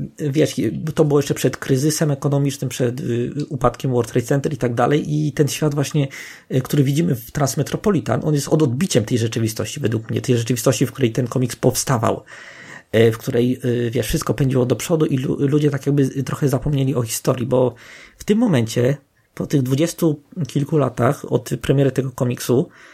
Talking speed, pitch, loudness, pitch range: 175 wpm, 135 Hz, -19 LUFS, 125-150 Hz